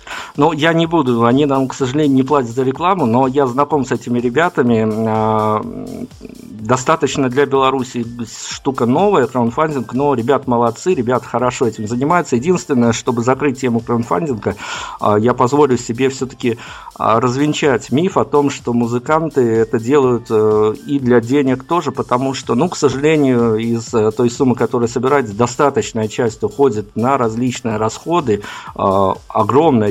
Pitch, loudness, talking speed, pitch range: 125 Hz, -15 LUFS, 140 wpm, 115-140 Hz